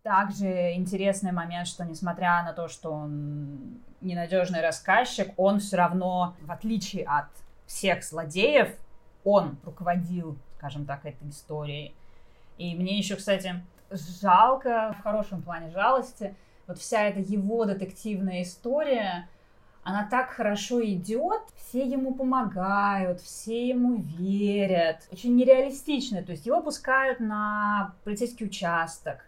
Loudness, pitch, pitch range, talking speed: -27 LUFS, 190 Hz, 175-215 Hz, 120 wpm